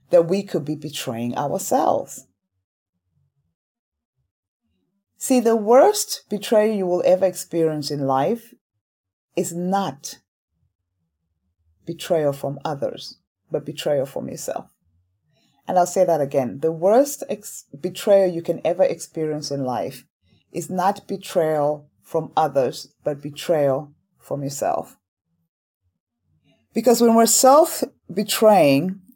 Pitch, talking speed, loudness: 150 Hz, 110 wpm, -21 LUFS